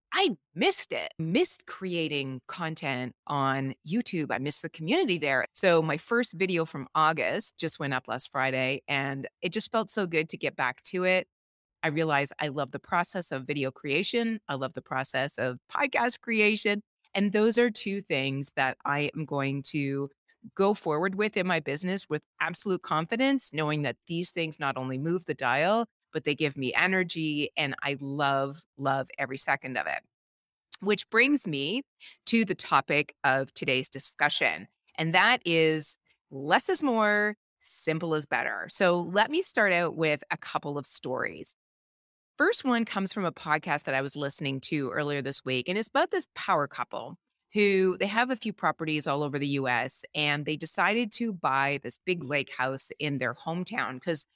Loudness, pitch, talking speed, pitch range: -28 LUFS, 155 Hz, 180 wpm, 140-200 Hz